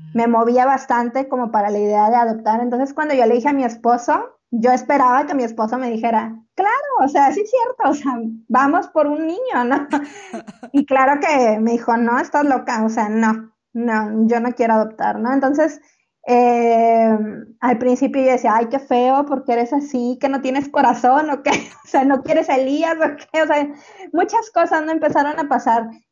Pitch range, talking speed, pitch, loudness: 235-290 Hz, 200 wpm, 255 Hz, -17 LUFS